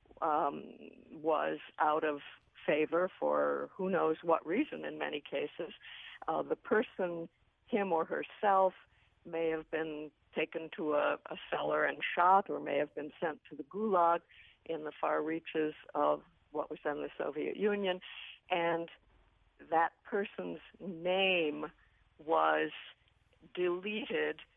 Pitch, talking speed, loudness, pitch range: 165 Hz, 130 wpm, -35 LUFS, 150-185 Hz